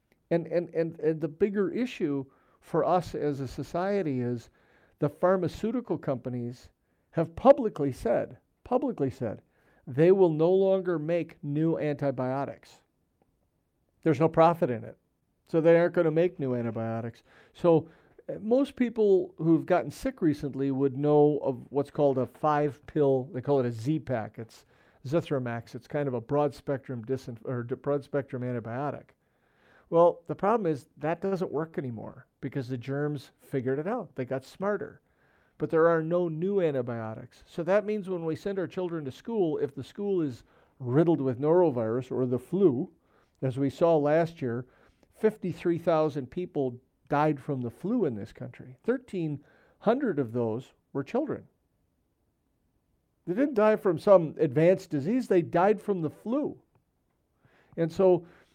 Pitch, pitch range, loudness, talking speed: 155 Hz, 135-180 Hz, -28 LUFS, 155 wpm